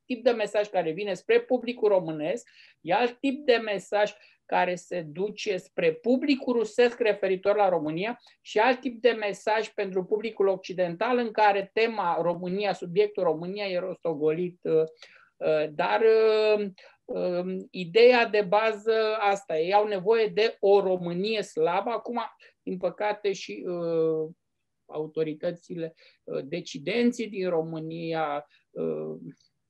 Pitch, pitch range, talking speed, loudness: 200 Hz, 175-225 Hz, 115 wpm, -27 LUFS